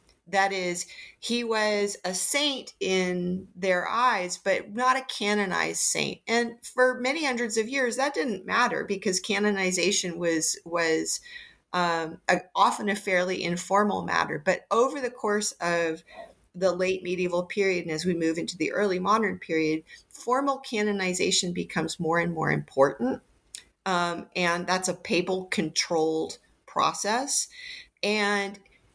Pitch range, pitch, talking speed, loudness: 175-220 Hz, 190 Hz, 140 wpm, -26 LUFS